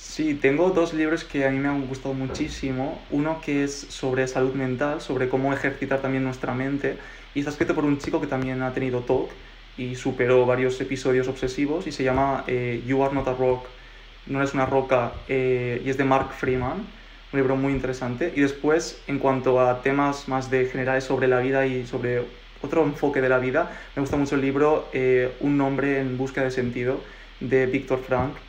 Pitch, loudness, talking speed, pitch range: 135 Hz, -24 LUFS, 200 wpm, 130-140 Hz